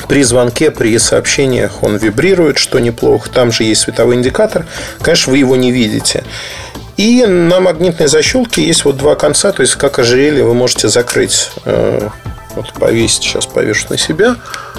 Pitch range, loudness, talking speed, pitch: 125-185 Hz, -10 LUFS, 160 wpm, 140 Hz